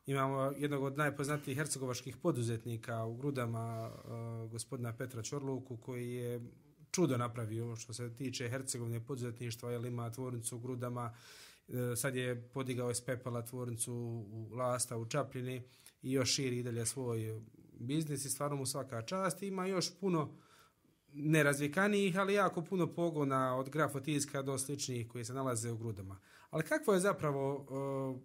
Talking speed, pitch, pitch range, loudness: 145 wpm, 130 Hz, 120-145 Hz, -38 LUFS